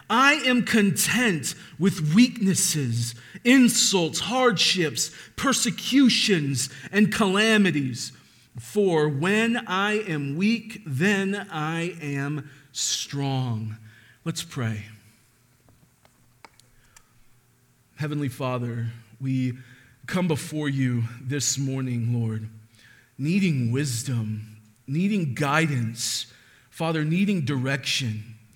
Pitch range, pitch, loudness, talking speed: 120-190 Hz, 140 Hz, -24 LUFS, 80 wpm